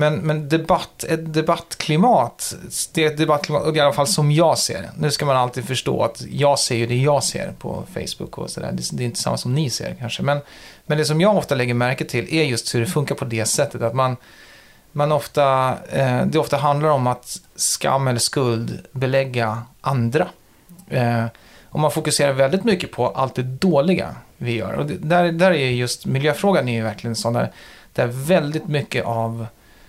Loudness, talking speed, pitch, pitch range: -20 LUFS, 200 wpm, 140 Hz, 120-155 Hz